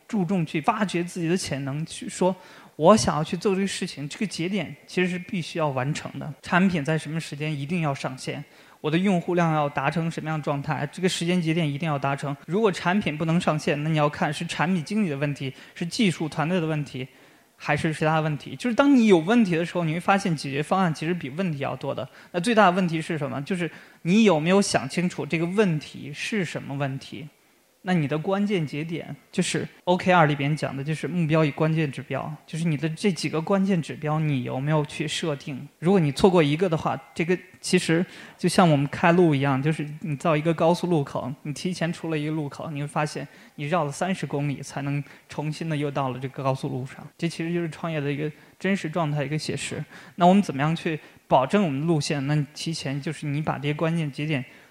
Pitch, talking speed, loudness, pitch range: 160 Hz, 340 characters per minute, -25 LUFS, 145-180 Hz